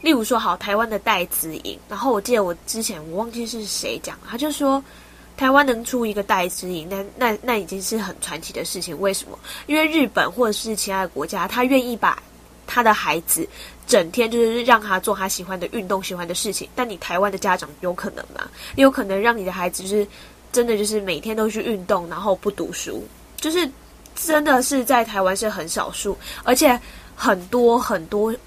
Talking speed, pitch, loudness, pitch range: 305 characters per minute, 215 Hz, -21 LUFS, 190-245 Hz